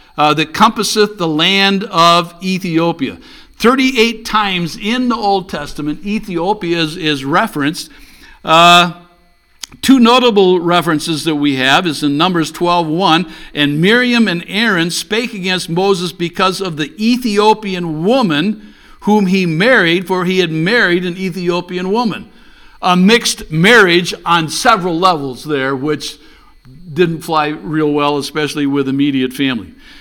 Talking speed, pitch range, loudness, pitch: 130 wpm, 160-205 Hz, -13 LUFS, 175 Hz